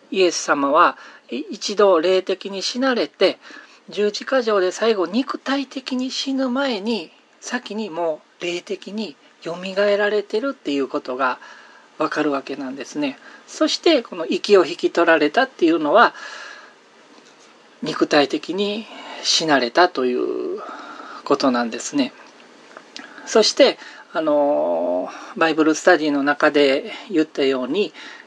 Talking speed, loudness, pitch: 245 characters per minute, -20 LUFS, 215 Hz